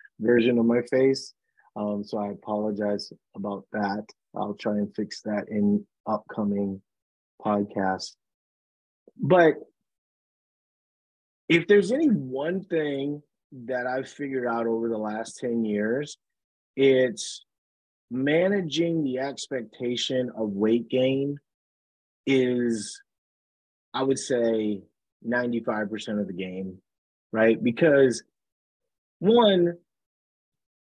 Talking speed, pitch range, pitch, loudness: 105 wpm, 105-140 Hz, 120 Hz, -26 LUFS